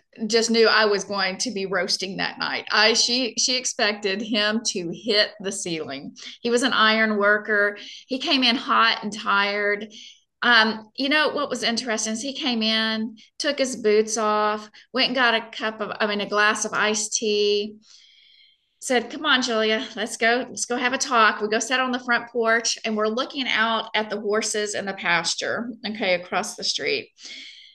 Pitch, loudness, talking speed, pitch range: 220 Hz, -22 LUFS, 190 wpm, 210-240 Hz